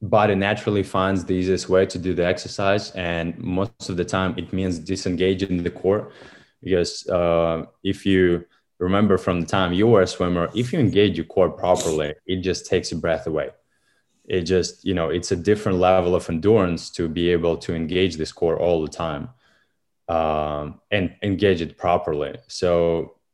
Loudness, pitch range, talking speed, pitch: -22 LUFS, 85-95 Hz, 180 wpm, 90 Hz